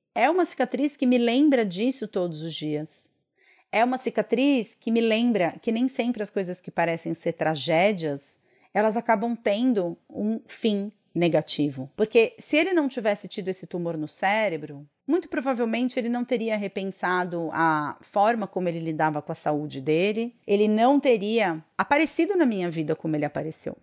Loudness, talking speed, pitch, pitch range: -25 LUFS, 165 wpm, 210 Hz, 165-240 Hz